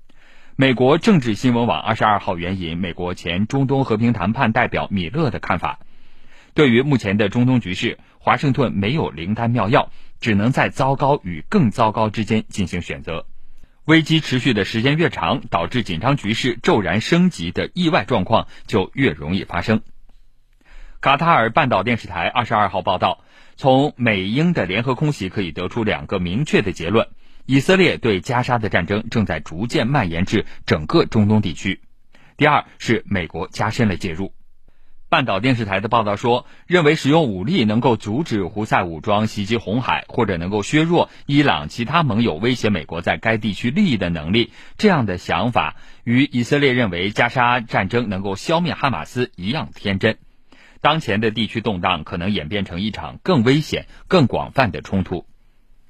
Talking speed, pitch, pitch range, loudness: 275 characters per minute, 115 Hz, 100-130 Hz, -19 LUFS